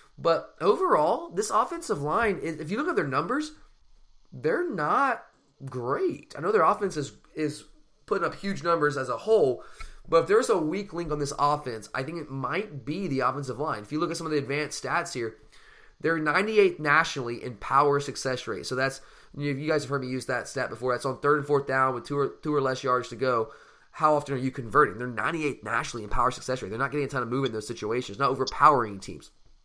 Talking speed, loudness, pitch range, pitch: 230 wpm, -27 LUFS, 130-155 Hz, 140 Hz